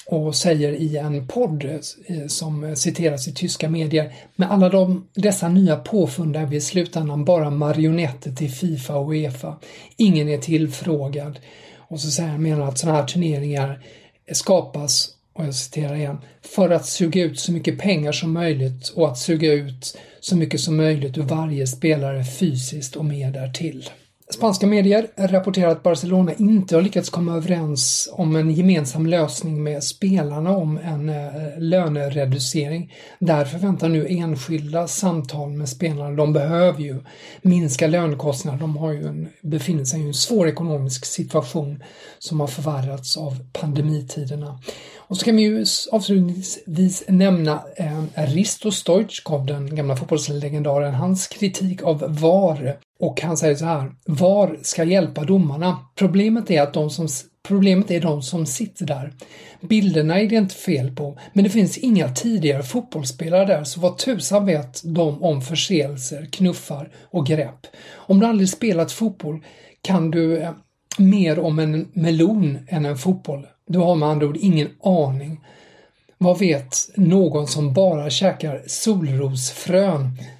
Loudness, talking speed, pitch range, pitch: -20 LUFS, 150 wpm, 145-180 Hz, 160 Hz